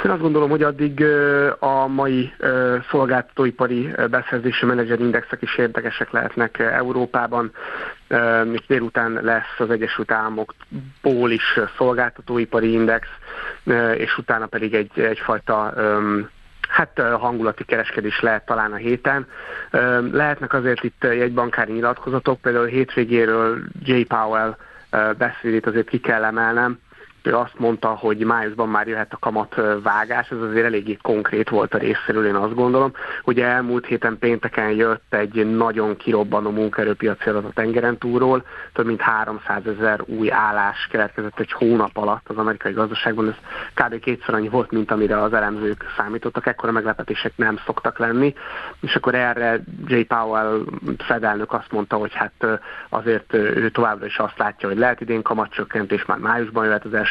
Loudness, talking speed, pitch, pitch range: -20 LUFS, 145 wpm, 115 Hz, 110-125 Hz